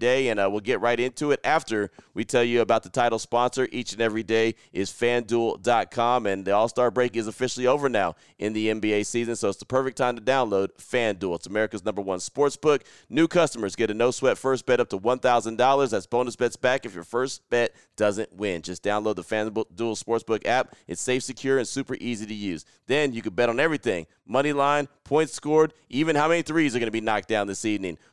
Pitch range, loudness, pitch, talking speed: 110-130 Hz, -25 LUFS, 120 Hz, 225 wpm